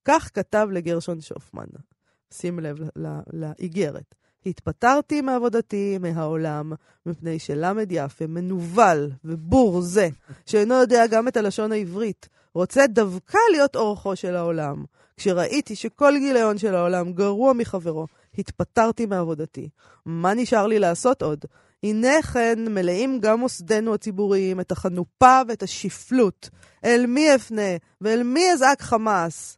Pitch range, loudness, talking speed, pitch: 170-235 Hz, -21 LUFS, 125 wpm, 200 Hz